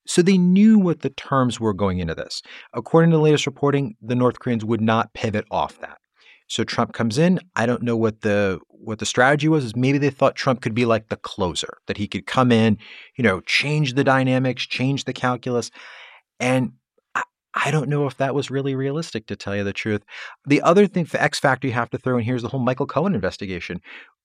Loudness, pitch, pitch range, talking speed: -21 LUFS, 125 Hz, 115-145 Hz, 230 wpm